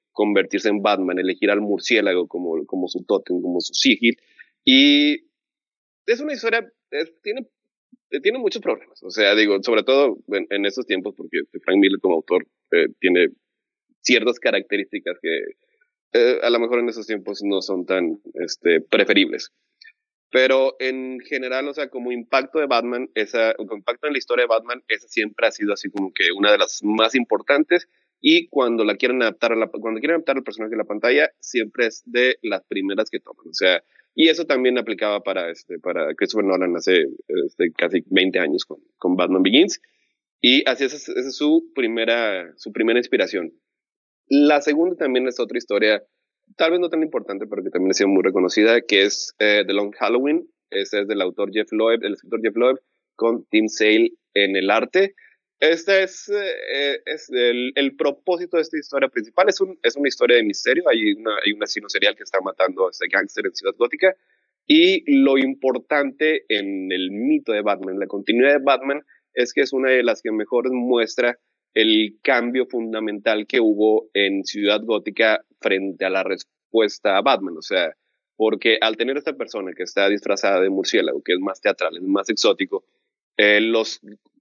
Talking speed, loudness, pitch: 185 wpm, -20 LUFS, 140 Hz